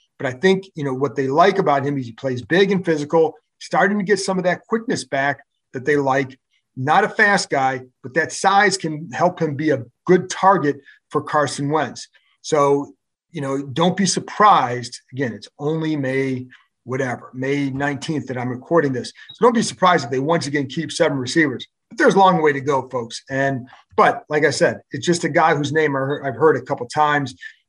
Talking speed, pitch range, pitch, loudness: 210 wpm, 135-170 Hz, 145 Hz, -19 LUFS